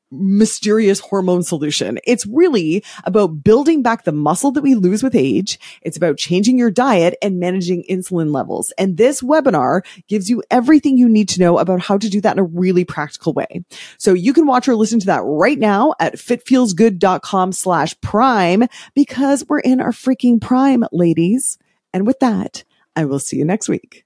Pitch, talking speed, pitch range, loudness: 215 Hz, 185 wpm, 185-255 Hz, -15 LUFS